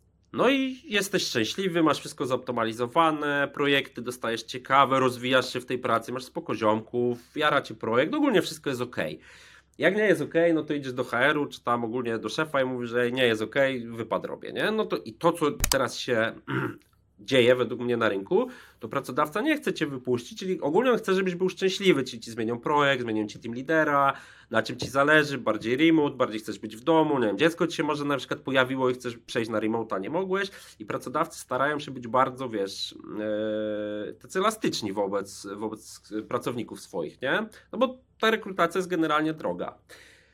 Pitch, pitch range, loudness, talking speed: 135 Hz, 115-160 Hz, -26 LUFS, 195 wpm